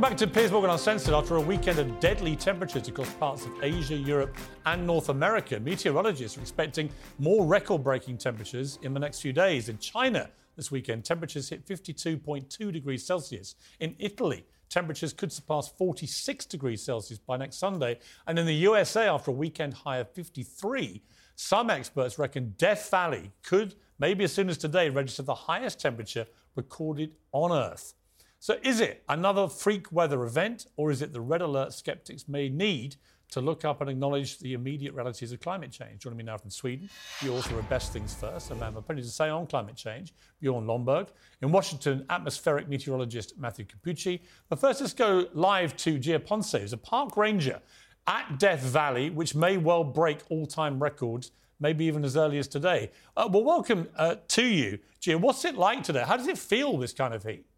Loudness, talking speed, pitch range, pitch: -29 LUFS, 190 wpm, 130-180 Hz, 150 Hz